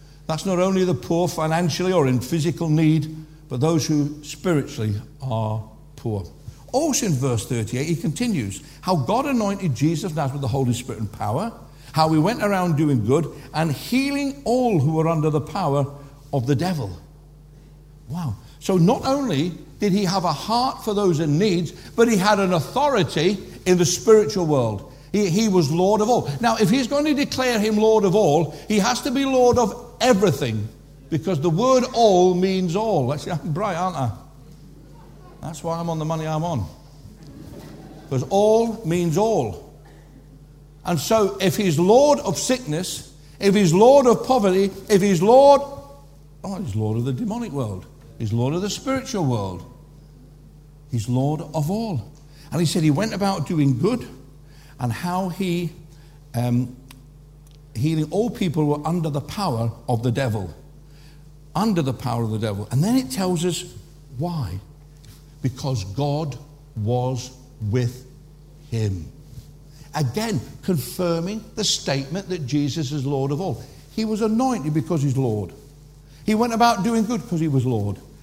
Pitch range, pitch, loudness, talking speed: 140-195 Hz, 155 Hz, -21 LUFS, 165 wpm